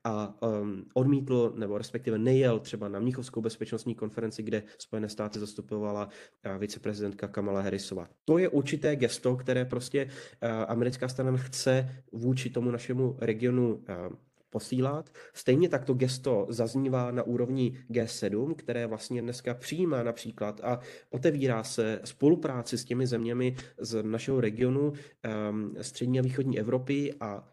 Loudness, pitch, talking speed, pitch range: -31 LUFS, 120 Hz, 130 wpm, 110-130 Hz